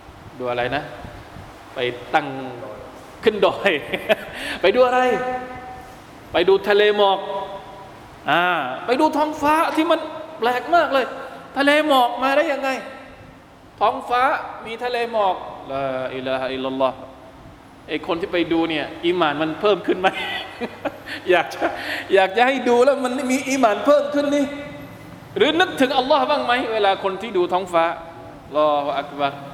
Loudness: -20 LUFS